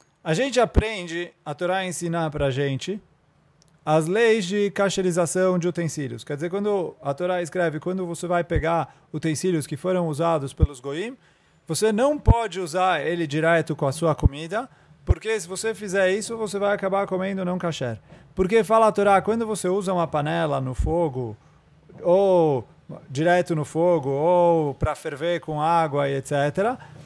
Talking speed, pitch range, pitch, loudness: 160 wpm, 155-190 Hz, 170 Hz, -23 LUFS